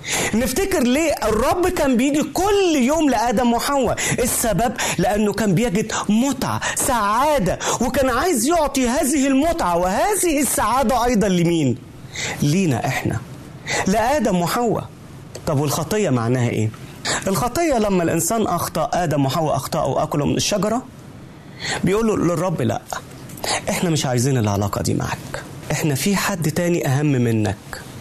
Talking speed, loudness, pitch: 120 wpm, -19 LUFS, 190 Hz